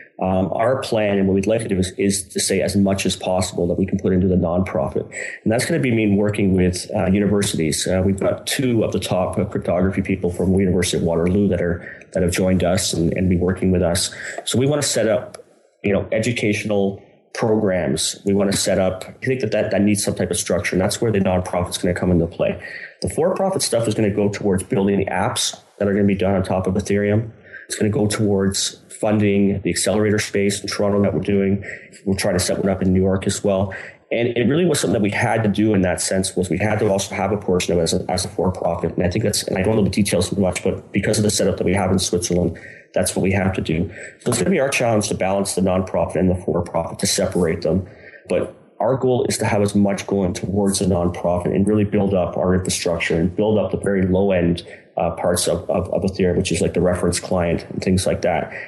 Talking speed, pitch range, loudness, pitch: 260 wpm, 90-100 Hz, -19 LUFS, 95 Hz